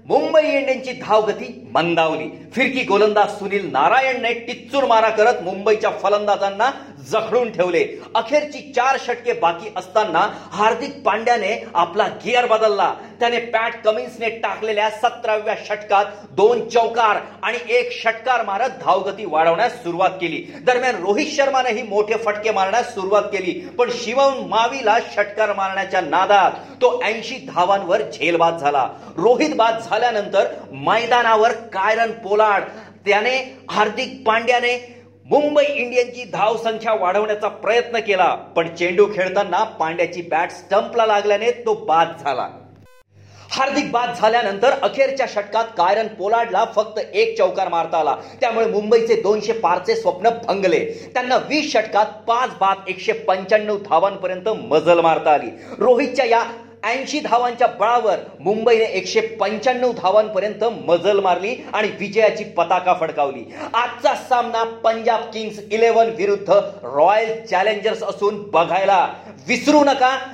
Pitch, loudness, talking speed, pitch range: 220 Hz, -18 LUFS, 120 wpm, 200-245 Hz